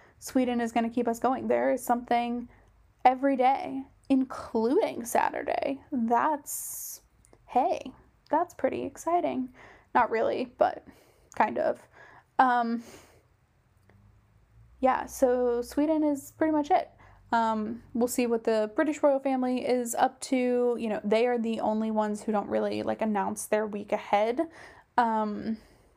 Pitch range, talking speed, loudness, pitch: 215-270 Hz, 135 wpm, -28 LUFS, 240 Hz